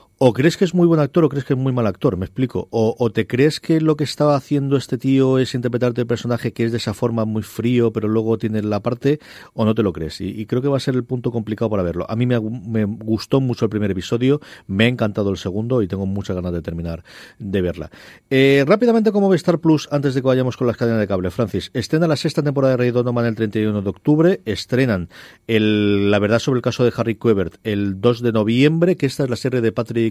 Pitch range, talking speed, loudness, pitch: 110-135 Hz, 260 wpm, -19 LUFS, 120 Hz